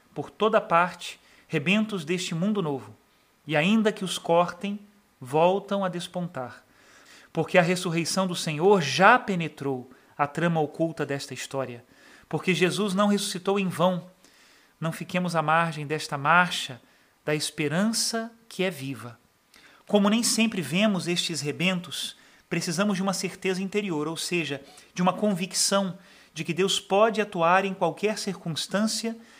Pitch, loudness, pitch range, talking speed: 180 Hz, -25 LUFS, 160-200 Hz, 140 wpm